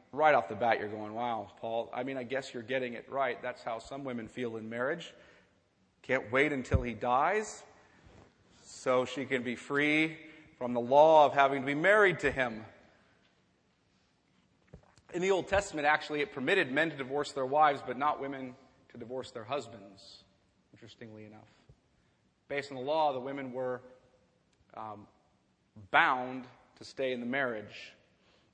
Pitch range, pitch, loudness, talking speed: 120-145 Hz, 130 Hz, -31 LUFS, 165 wpm